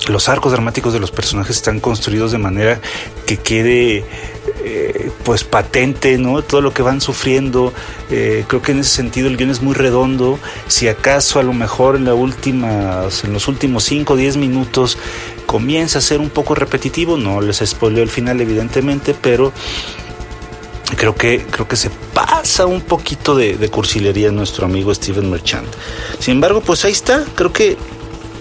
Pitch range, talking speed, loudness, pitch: 110-140 Hz, 175 wpm, -14 LUFS, 125 Hz